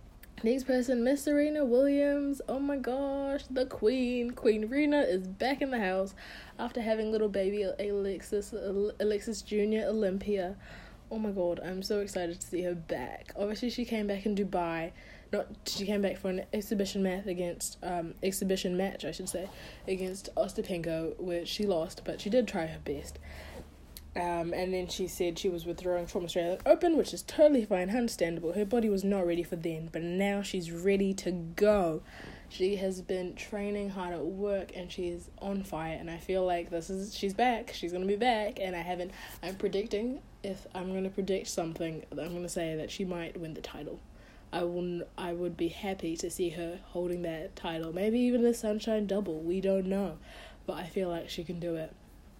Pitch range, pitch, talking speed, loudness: 175-210 Hz, 190 Hz, 195 wpm, -33 LUFS